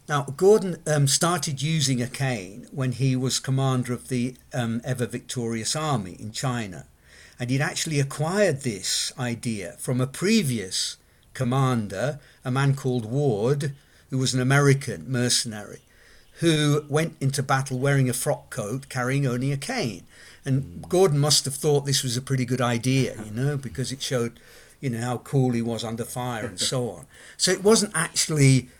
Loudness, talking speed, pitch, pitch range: -24 LUFS, 165 wpm, 130 Hz, 125-145 Hz